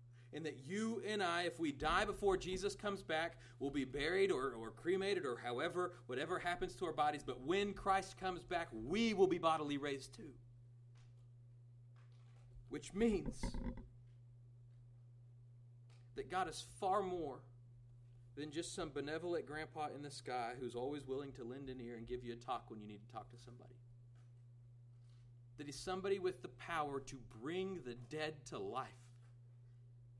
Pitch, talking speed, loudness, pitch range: 130 Hz, 165 wpm, -42 LUFS, 120-170 Hz